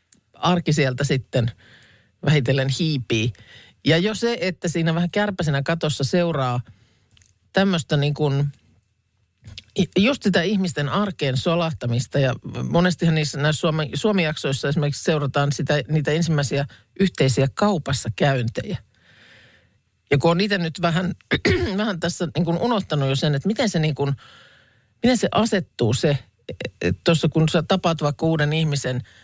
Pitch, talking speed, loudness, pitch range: 150 Hz, 130 wpm, -21 LUFS, 130-170 Hz